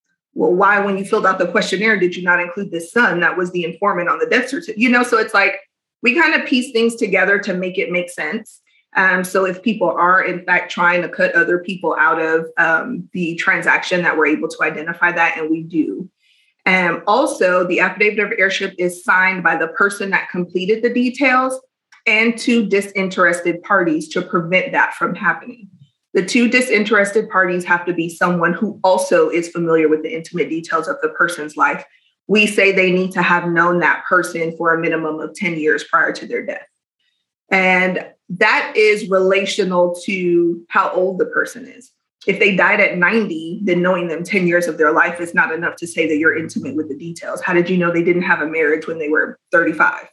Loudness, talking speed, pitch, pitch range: -16 LUFS, 210 wpm, 185 Hz, 170-215 Hz